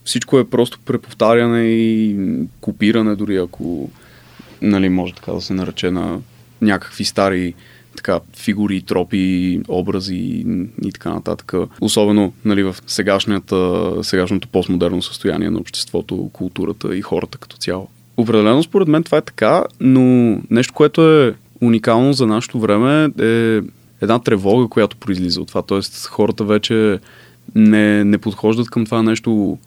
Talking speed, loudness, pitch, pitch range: 135 wpm, -16 LUFS, 105 Hz, 95-120 Hz